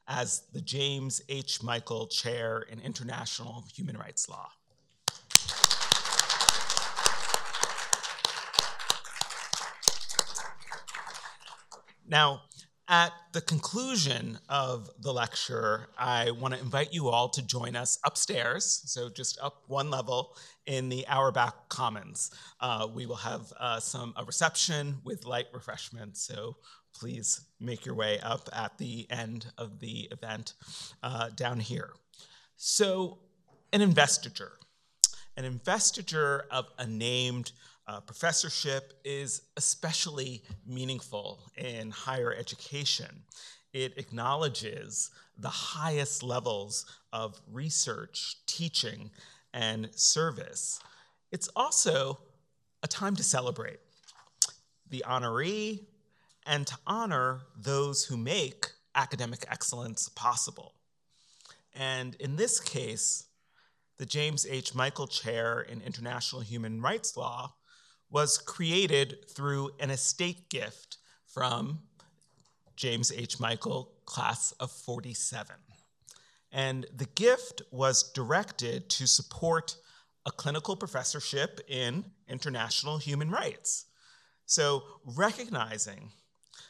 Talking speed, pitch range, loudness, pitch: 105 wpm, 120-155 Hz, -31 LUFS, 135 Hz